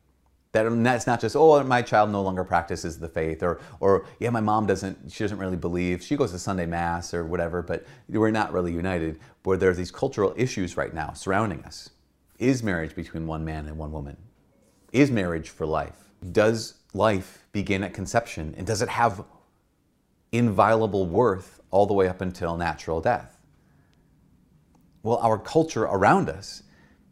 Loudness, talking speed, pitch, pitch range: -25 LUFS, 175 wpm, 95 Hz, 85-110 Hz